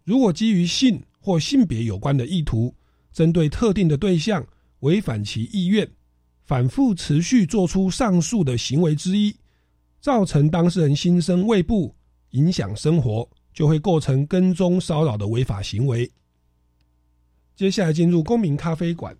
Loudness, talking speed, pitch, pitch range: -21 LUFS, 230 characters per minute, 160 Hz, 115-185 Hz